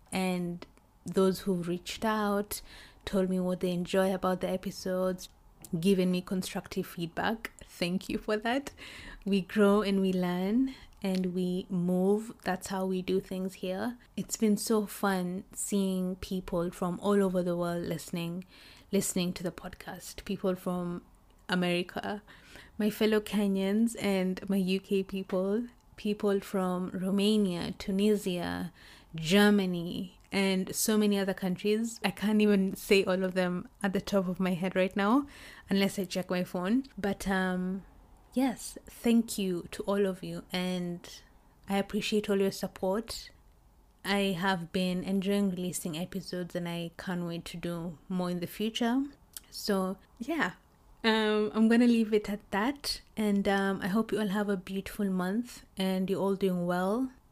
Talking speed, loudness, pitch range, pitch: 155 wpm, -31 LUFS, 185-205 Hz, 195 Hz